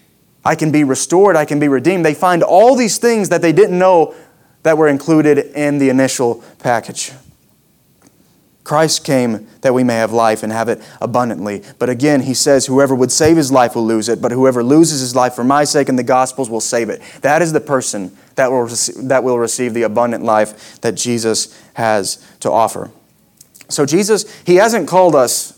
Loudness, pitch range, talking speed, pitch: -14 LUFS, 120-155 Hz, 200 wpm, 135 Hz